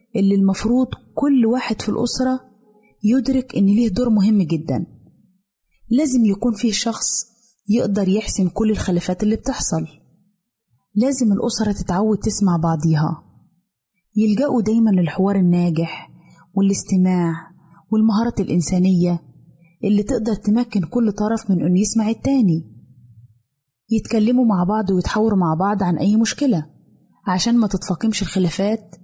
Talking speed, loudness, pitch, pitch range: 115 wpm, -19 LUFS, 205 Hz, 180-225 Hz